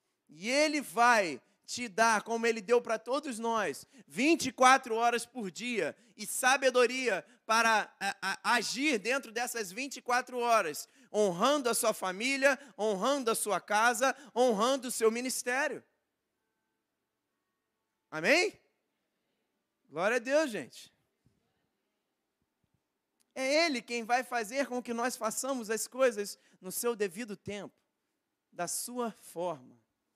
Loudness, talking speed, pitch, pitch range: -30 LUFS, 120 wpm, 240 Hz, 220-260 Hz